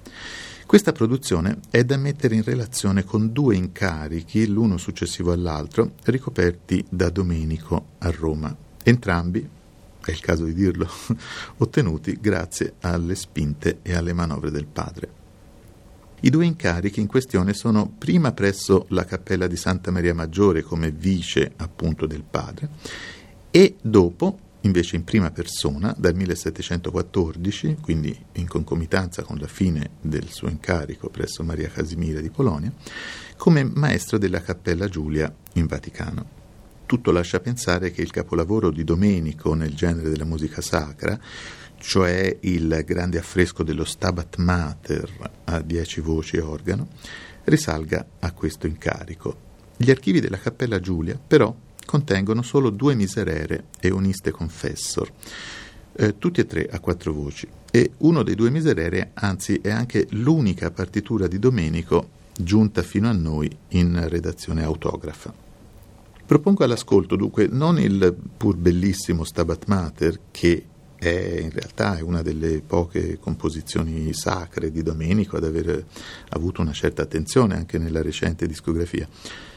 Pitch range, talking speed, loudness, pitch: 80-105 Hz, 135 wpm, -23 LUFS, 90 Hz